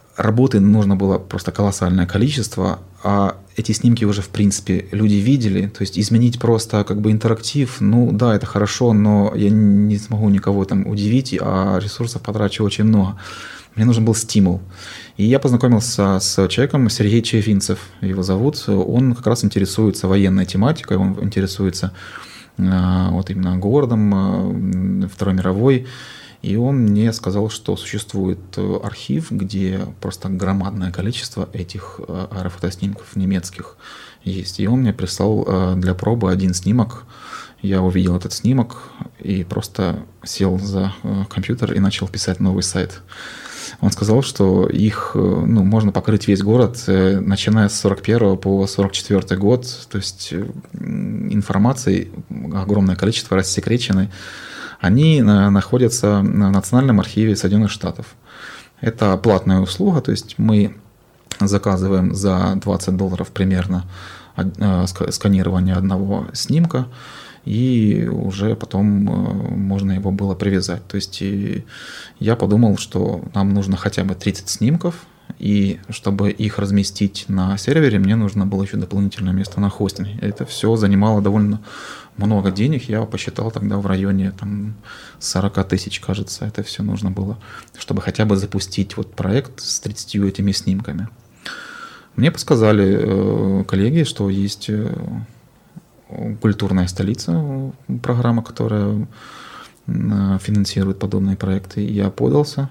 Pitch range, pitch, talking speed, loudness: 95-110 Hz, 100 Hz, 125 wpm, -18 LUFS